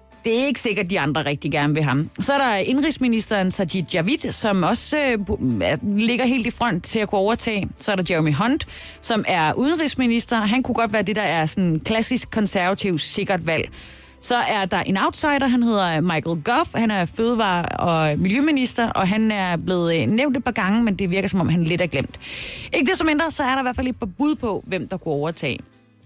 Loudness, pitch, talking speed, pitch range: -21 LUFS, 205 Hz, 220 wpm, 175-240 Hz